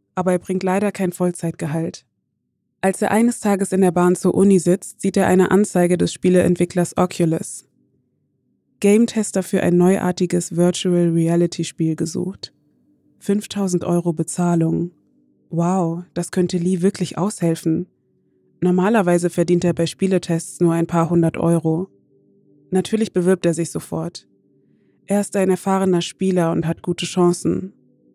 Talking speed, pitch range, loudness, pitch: 130 wpm, 170-190 Hz, -19 LUFS, 180 Hz